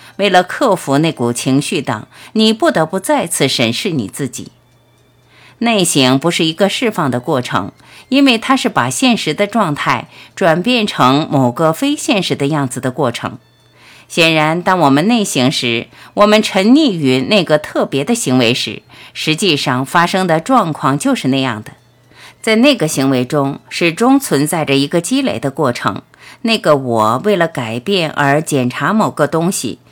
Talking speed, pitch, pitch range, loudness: 245 characters per minute, 150 Hz, 130-200 Hz, -14 LUFS